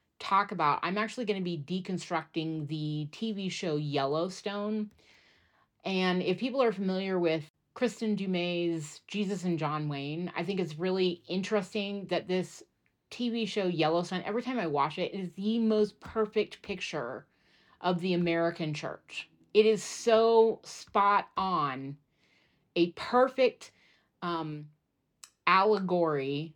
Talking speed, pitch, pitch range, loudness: 130 wpm, 185 Hz, 160-210 Hz, -30 LUFS